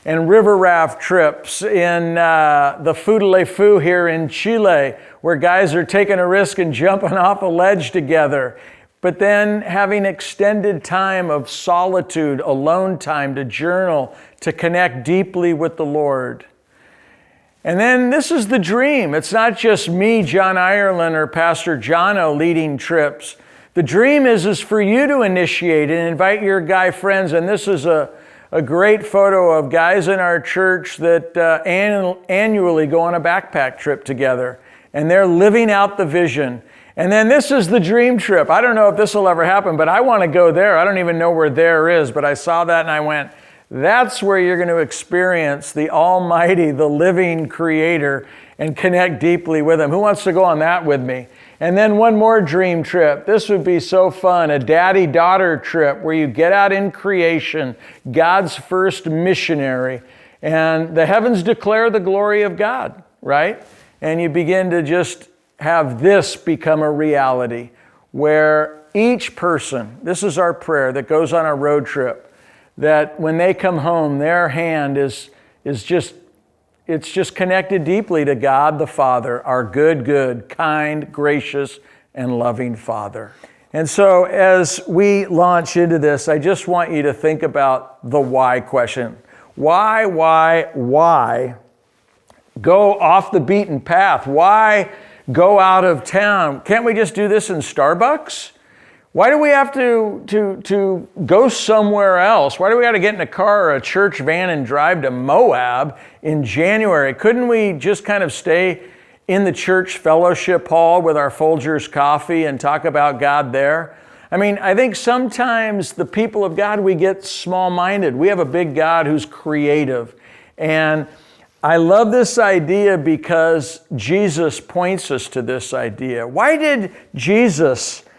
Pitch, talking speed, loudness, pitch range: 175 Hz, 170 wpm, -15 LUFS, 155-195 Hz